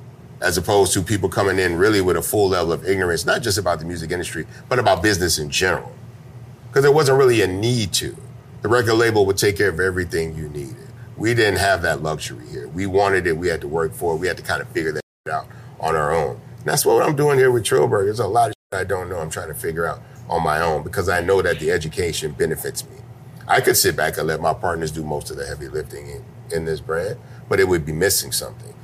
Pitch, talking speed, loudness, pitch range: 120 Hz, 255 wpm, -20 LUFS, 95-130 Hz